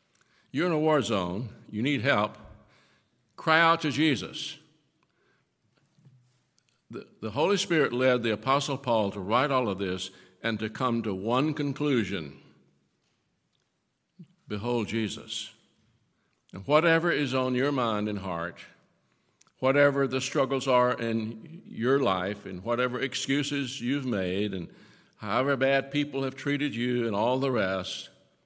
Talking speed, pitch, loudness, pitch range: 135 wpm, 125 Hz, -28 LUFS, 105-140 Hz